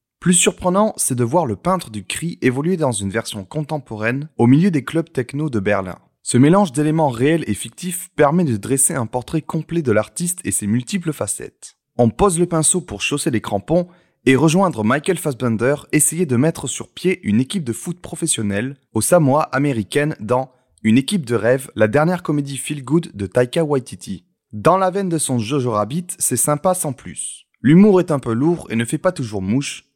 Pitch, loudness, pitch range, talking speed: 145 Hz, -18 LUFS, 120-175 Hz, 200 wpm